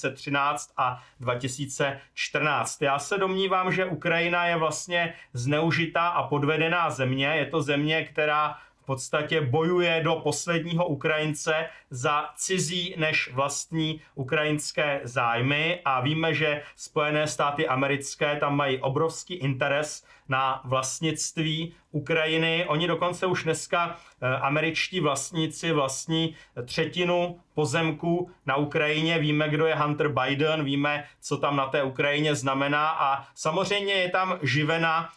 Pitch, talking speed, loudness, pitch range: 155 Hz, 120 wpm, -26 LUFS, 140-165 Hz